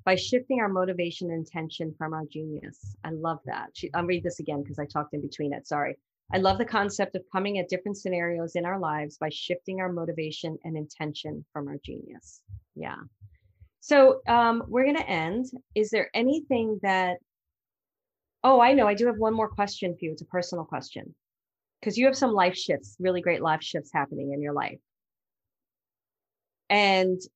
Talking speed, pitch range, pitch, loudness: 185 wpm, 155-205 Hz, 180 Hz, -27 LUFS